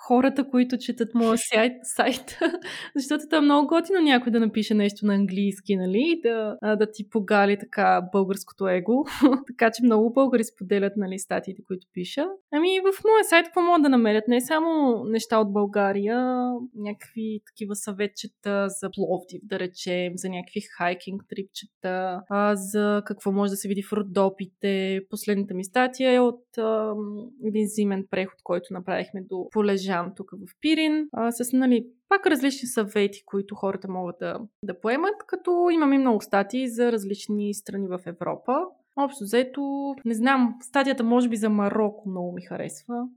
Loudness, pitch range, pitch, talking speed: -24 LUFS, 200-250 Hz, 215 Hz, 160 wpm